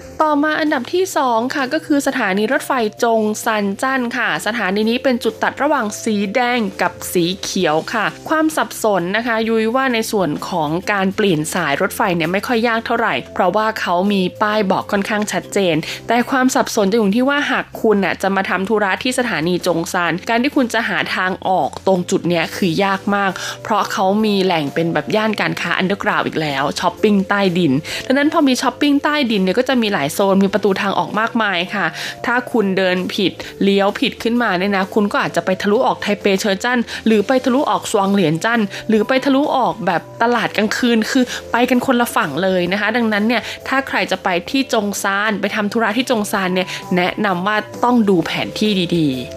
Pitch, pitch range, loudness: 210 Hz, 190-240 Hz, -17 LUFS